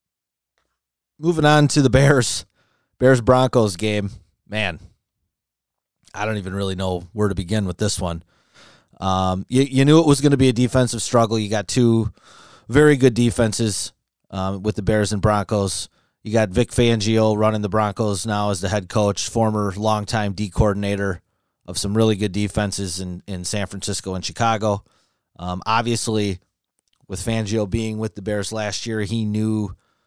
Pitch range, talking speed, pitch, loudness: 100-115 Hz, 165 wpm, 105 Hz, -20 LUFS